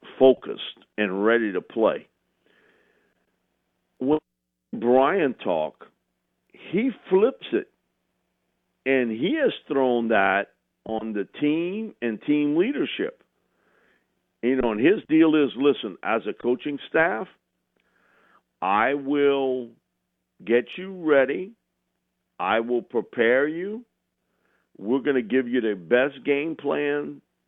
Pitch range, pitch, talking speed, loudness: 110-145 Hz, 130 Hz, 110 wpm, -24 LUFS